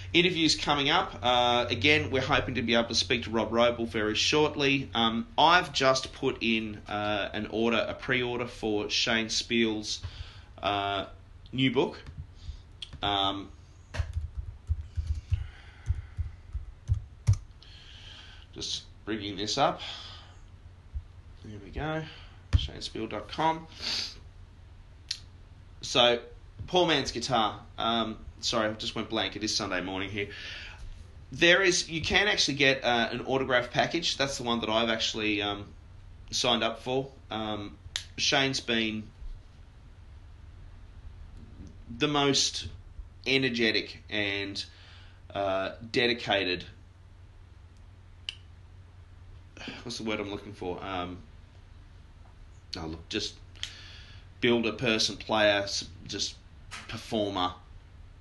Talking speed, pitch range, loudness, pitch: 105 wpm, 90-115 Hz, -28 LUFS, 100 Hz